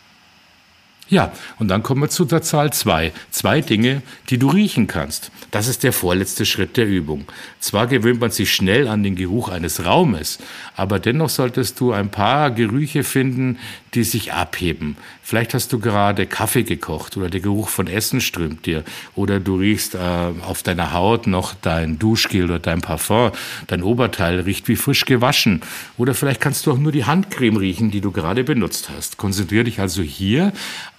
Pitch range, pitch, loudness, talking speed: 95-125 Hz, 110 Hz, -19 LUFS, 180 wpm